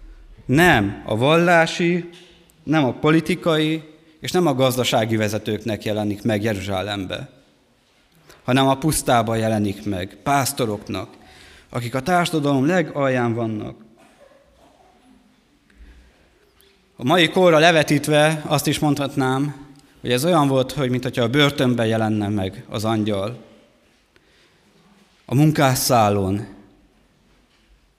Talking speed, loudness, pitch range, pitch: 100 wpm, -19 LUFS, 105-155 Hz, 130 Hz